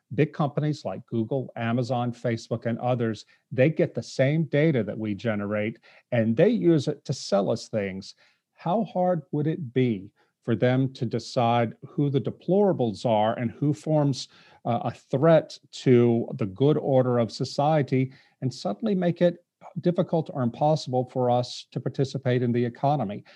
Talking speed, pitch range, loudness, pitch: 160 wpm, 120-155 Hz, -25 LUFS, 130 Hz